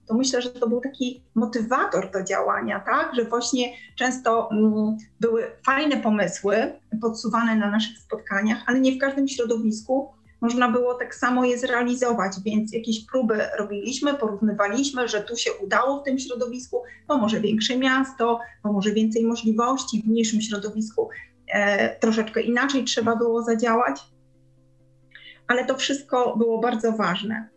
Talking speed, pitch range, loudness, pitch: 145 wpm, 215-250 Hz, -23 LUFS, 235 Hz